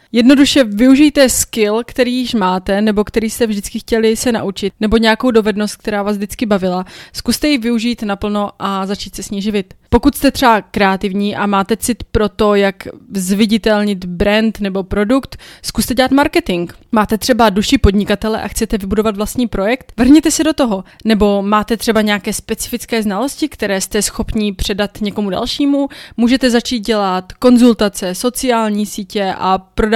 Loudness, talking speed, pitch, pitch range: -14 LUFS, 160 wpm, 220 Hz, 205-240 Hz